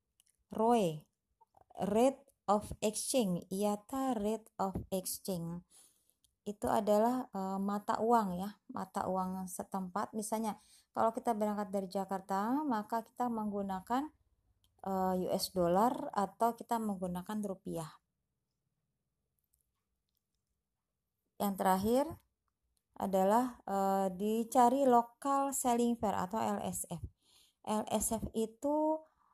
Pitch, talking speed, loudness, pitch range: 215 Hz, 90 wpm, -35 LUFS, 195-235 Hz